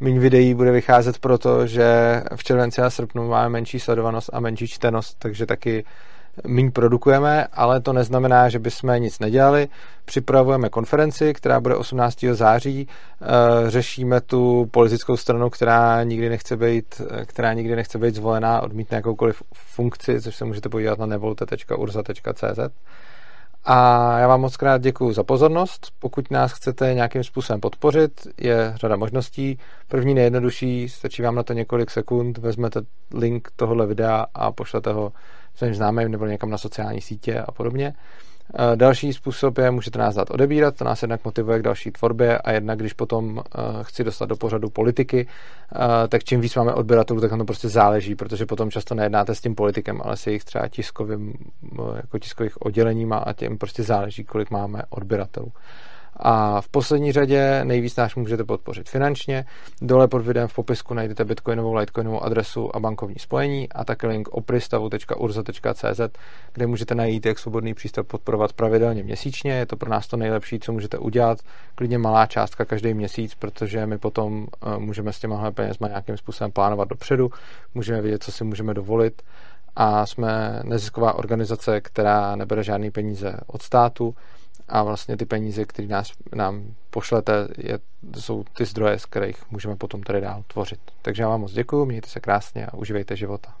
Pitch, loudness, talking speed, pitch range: 115 Hz, -21 LUFS, 165 wpm, 110-125 Hz